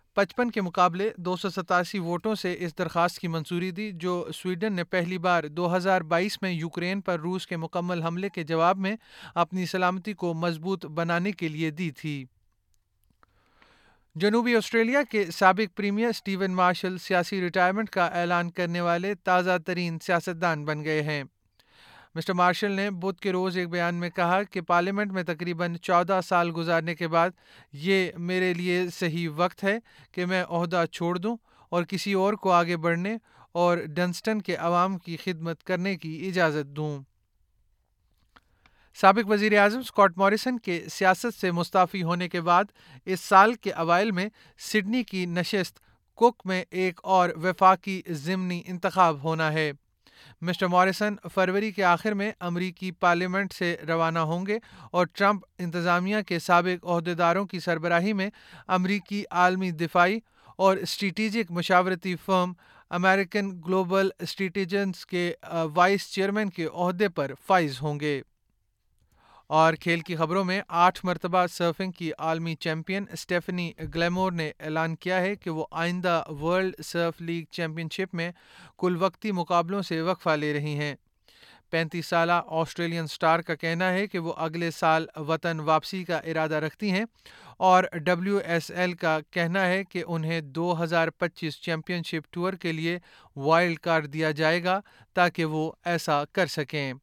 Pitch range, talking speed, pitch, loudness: 165-190 Hz, 155 wpm, 175 Hz, -26 LUFS